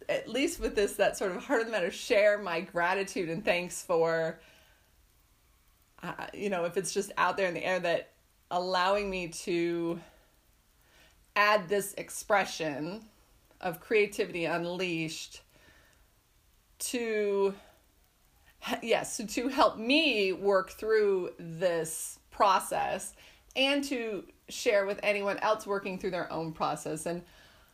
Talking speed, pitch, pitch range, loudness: 130 wpm, 185 Hz, 165-205 Hz, -30 LUFS